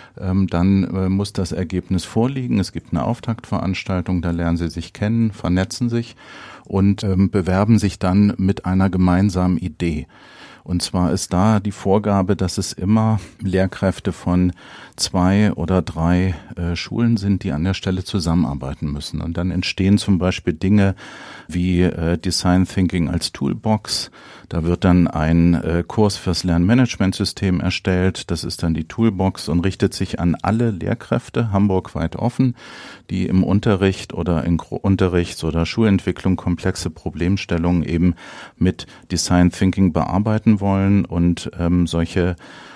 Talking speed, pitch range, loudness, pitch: 145 wpm, 85-100 Hz, -19 LUFS, 95 Hz